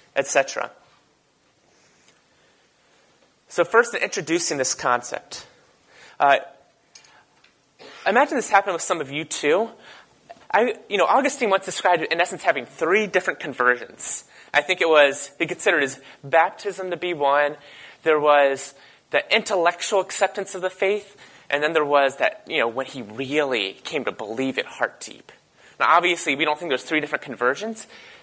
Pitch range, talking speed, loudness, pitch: 145-195 Hz, 155 wpm, -22 LUFS, 165 Hz